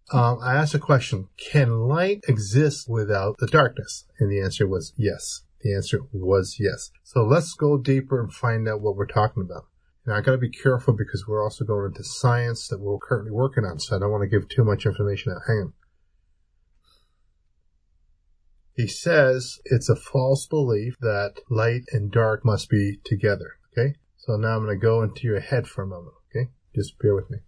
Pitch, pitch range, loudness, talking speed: 115 Hz, 100-130 Hz, -24 LUFS, 195 wpm